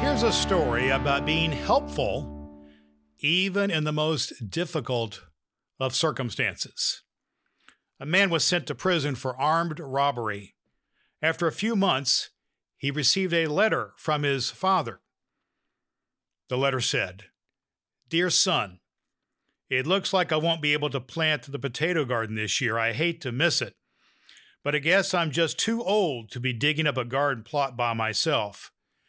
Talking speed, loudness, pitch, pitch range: 150 wpm, -25 LUFS, 145 Hz, 120-165 Hz